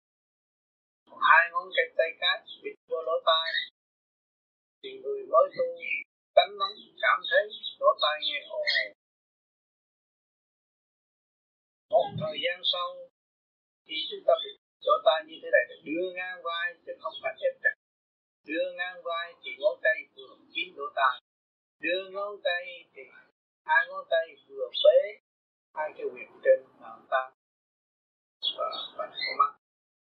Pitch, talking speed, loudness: 305 Hz, 145 wpm, -28 LUFS